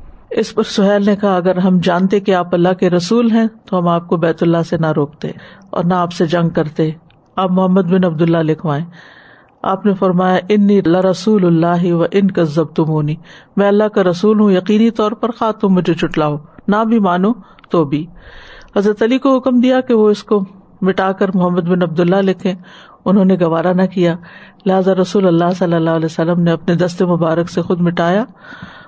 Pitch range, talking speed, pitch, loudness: 170-205 Hz, 200 wpm, 185 Hz, -14 LUFS